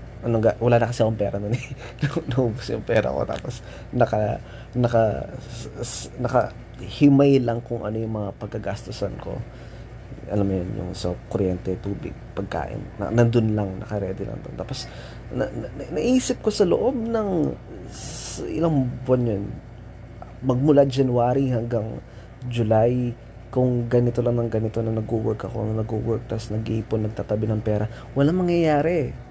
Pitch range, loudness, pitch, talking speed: 110-125 Hz, -24 LUFS, 115 Hz, 145 wpm